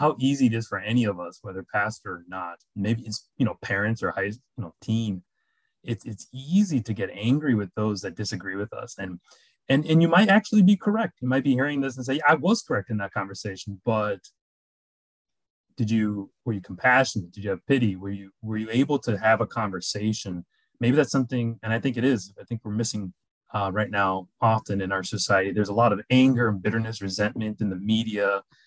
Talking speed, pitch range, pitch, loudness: 220 wpm, 100-130 Hz, 110 Hz, -25 LUFS